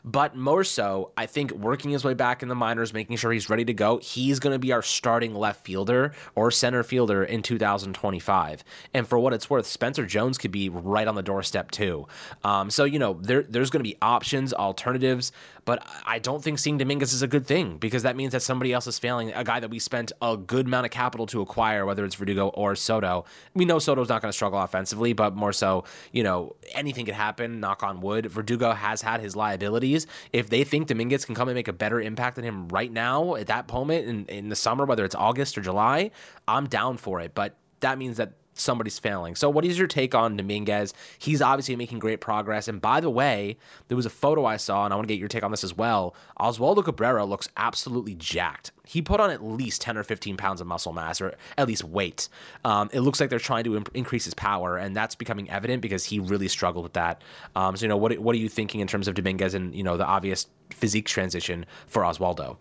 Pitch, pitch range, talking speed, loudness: 115 Hz, 100-125 Hz, 240 wpm, -26 LUFS